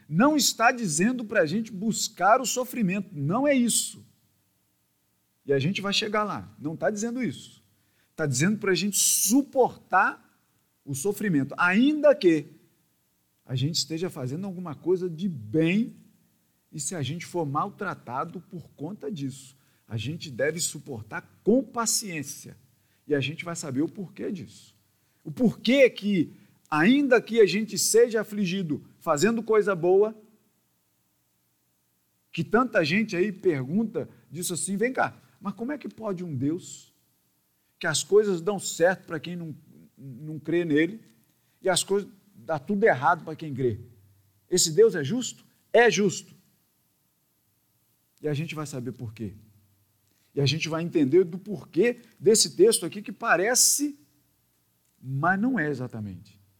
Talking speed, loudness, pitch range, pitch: 150 wpm, -25 LUFS, 135-210 Hz, 170 Hz